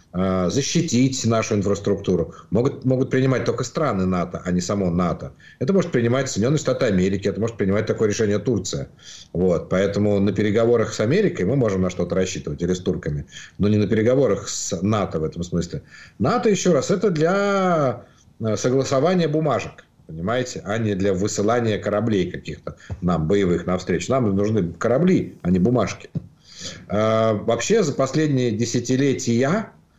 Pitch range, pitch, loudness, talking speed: 100-130 Hz, 110 Hz, -21 LUFS, 150 wpm